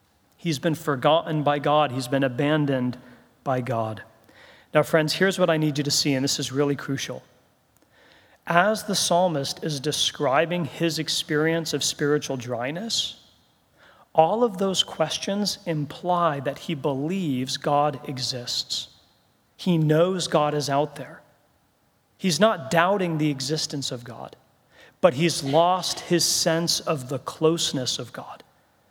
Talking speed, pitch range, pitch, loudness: 140 wpm, 140-170 Hz, 150 Hz, -24 LUFS